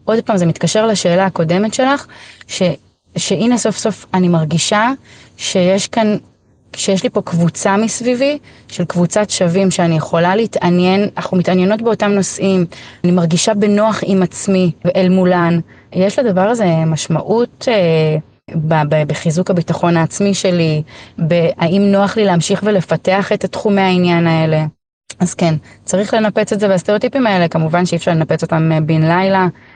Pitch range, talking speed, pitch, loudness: 165-205 Hz, 145 wpm, 180 Hz, -14 LUFS